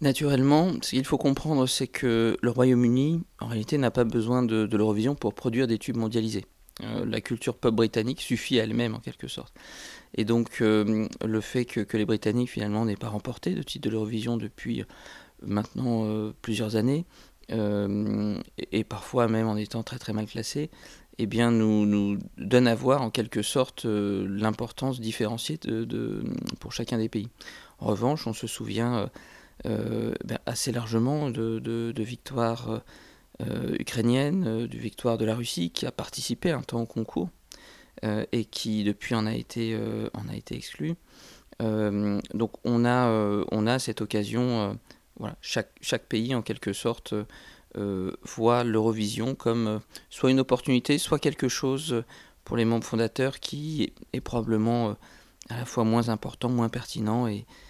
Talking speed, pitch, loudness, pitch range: 175 wpm, 115 Hz, -28 LUFS, 110-125 Hz